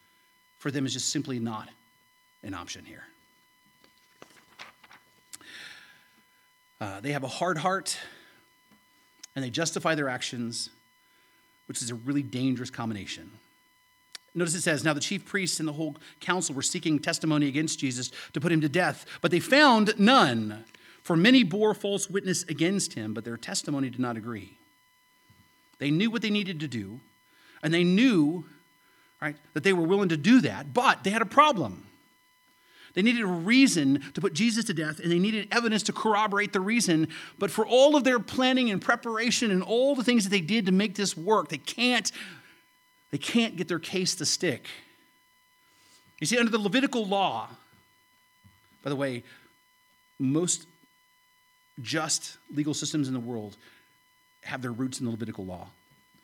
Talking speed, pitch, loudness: 165 wpm, 180 Hz, -26 LUFS